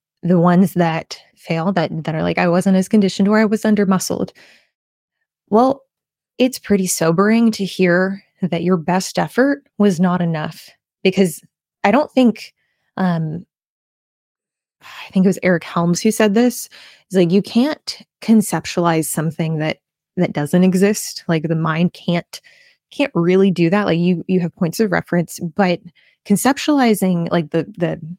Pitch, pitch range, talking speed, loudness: 185 Hz, 170-215 Hz, 160 wpm, -17 LUFS